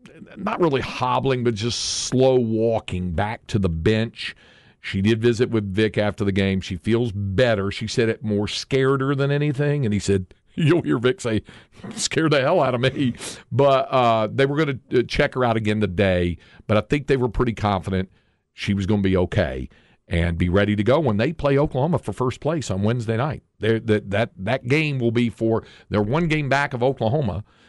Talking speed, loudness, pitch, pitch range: 205 wpm, -22 LUFS, 115 Hz, 100-130 Hz